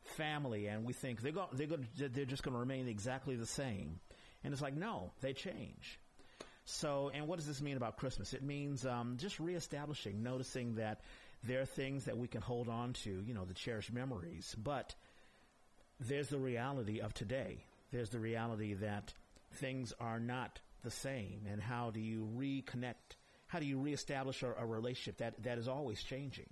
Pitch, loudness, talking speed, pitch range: 125 Hz, -44 LUFS, 190 wpm, 110-135 Hz